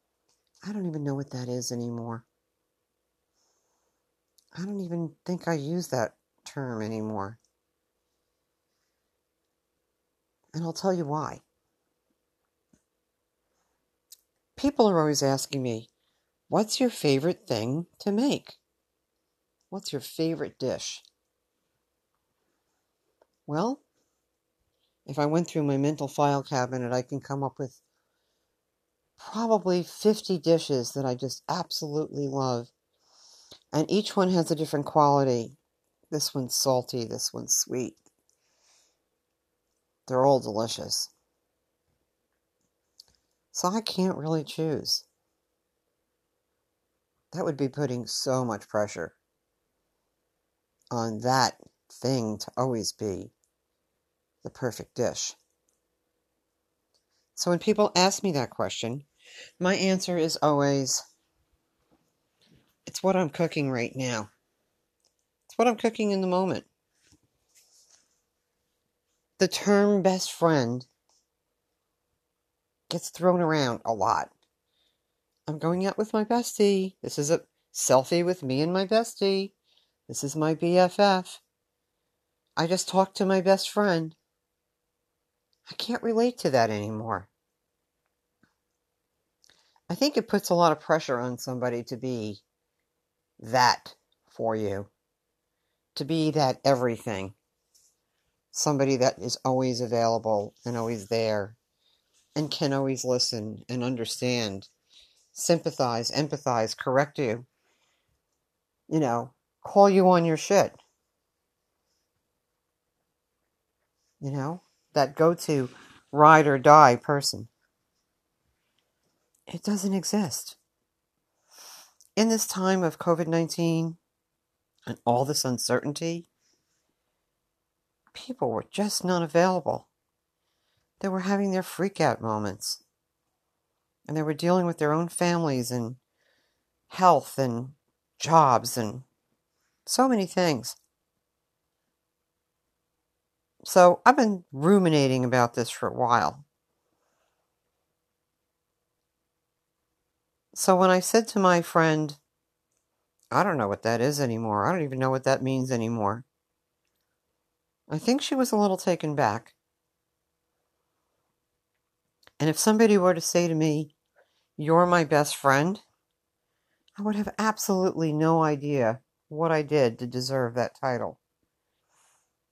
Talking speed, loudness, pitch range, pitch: 110 wpm, -26 LUFS, 125-180 Hz, 150 Hz